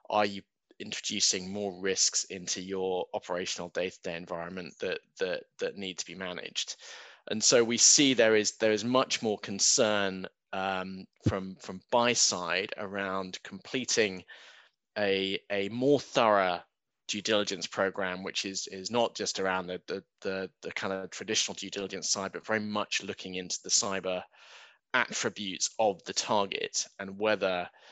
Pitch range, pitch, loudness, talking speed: 95-115 Hz, 100 Hz, -29 LUFS, 155 wpm